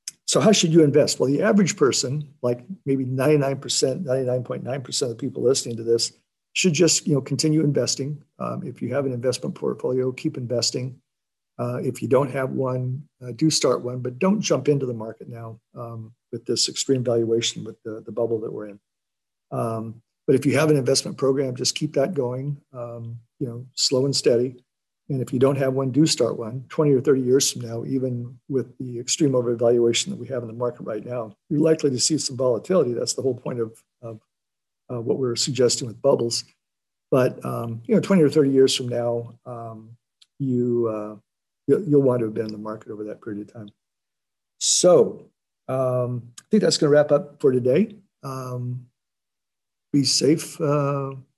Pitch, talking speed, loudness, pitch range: 130 Hz, 195 wpm, -22 LUFS, 120-145 Hz